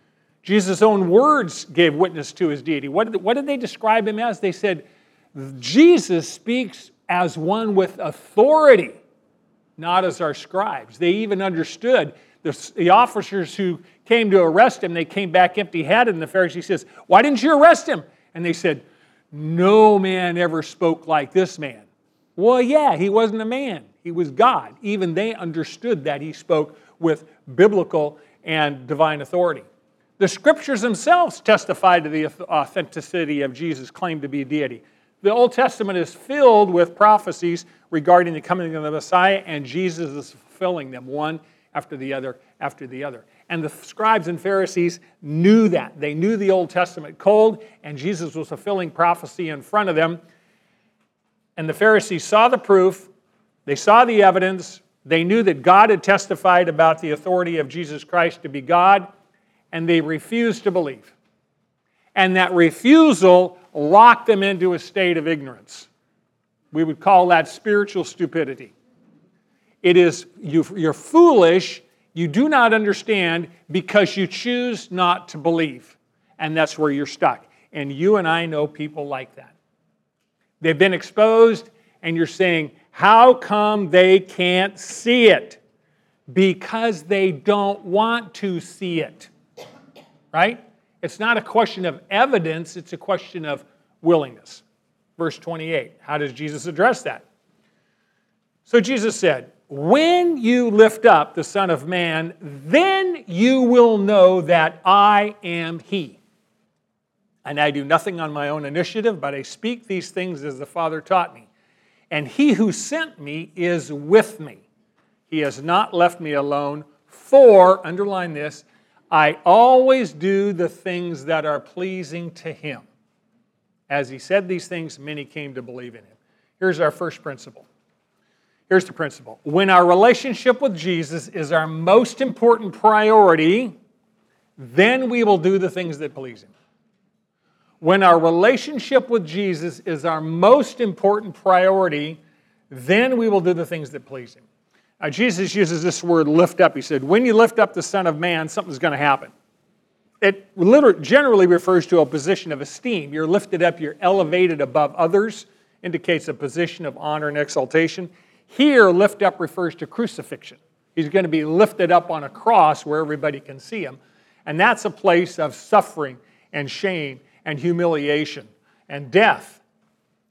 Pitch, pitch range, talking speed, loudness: 180 Hz, 155-205 Hz, 160 wpm, -18 LUFS